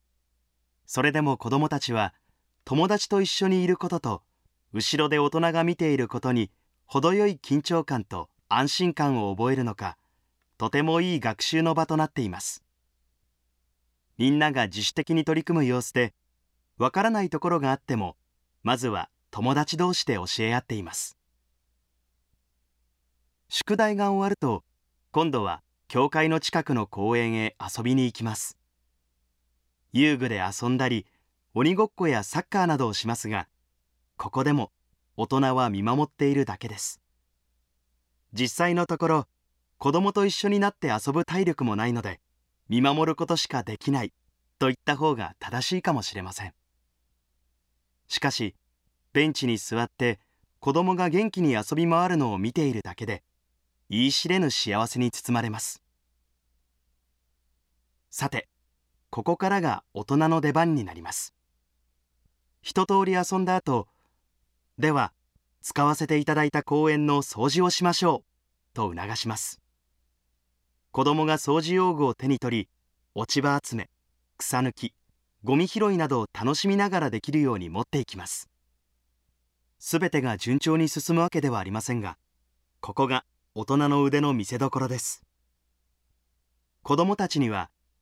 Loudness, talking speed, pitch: -26 LUFS, 275 characters per minute, 115 Hz